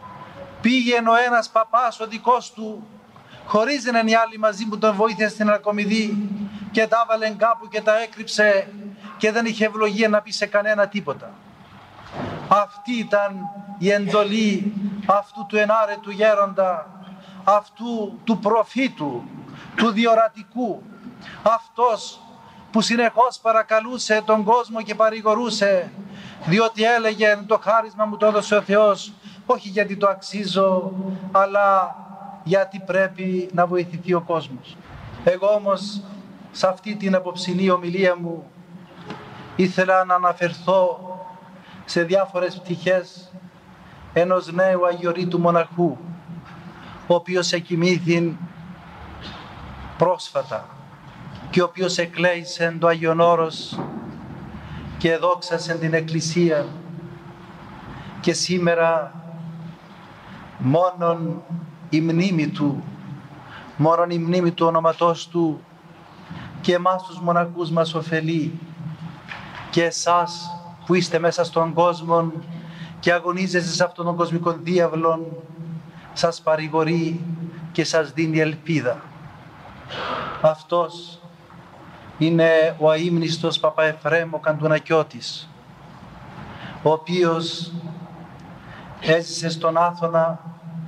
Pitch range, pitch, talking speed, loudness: 165-205 Hz, 180 Hz, 100 wpm, -21 LUFS